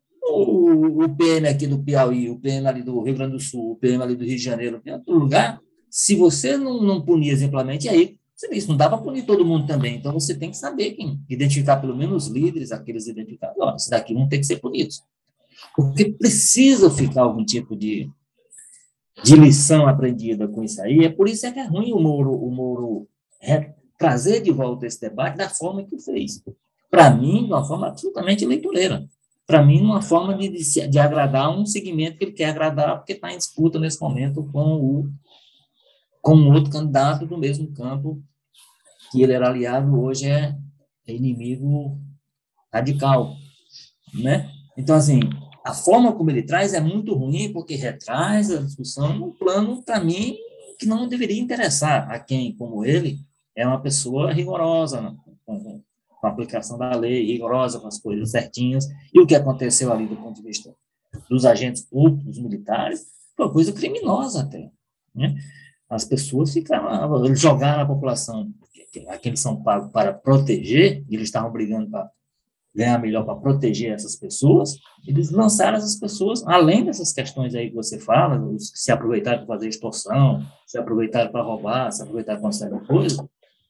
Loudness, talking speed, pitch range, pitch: -20 LUFS, 180 wpm, 125-170 Hz, 145 Hz